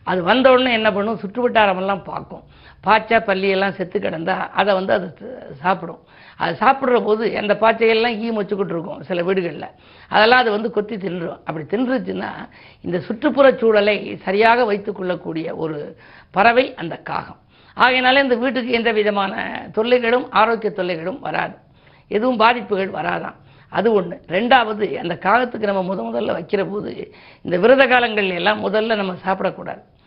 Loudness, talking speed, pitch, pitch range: -18 LUFS, 140 wpm, 210 Hz, 190-235 Hz